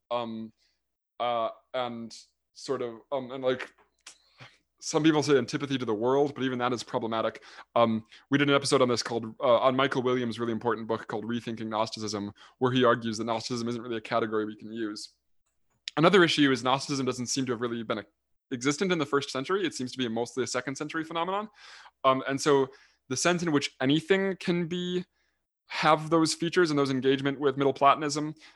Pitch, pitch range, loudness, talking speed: 130 Hz, 115-145 Hz, -28 LUFS, 200 wpm